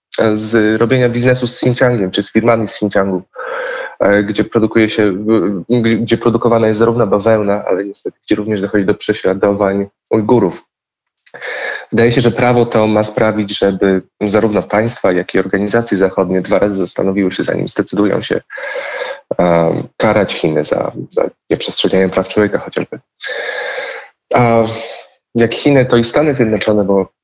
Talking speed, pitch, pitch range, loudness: 140 wpm, 110 Hz, 100-115 Hz, -14 LUFS